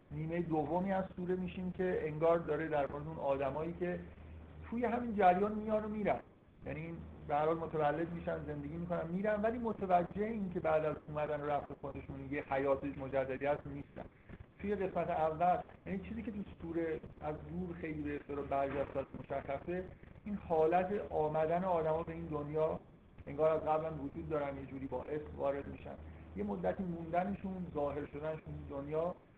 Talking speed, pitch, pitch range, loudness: 165 wpm, 155 Hz, 140-180 Hz, -38 LUFS